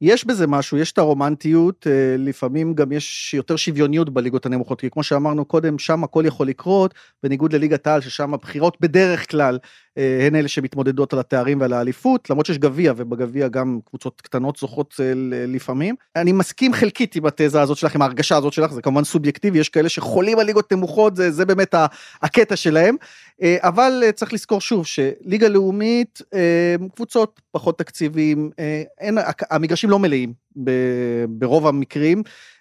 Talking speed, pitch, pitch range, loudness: 155 wpm, 155 Hz, 140-180 Hz, -19 LUFS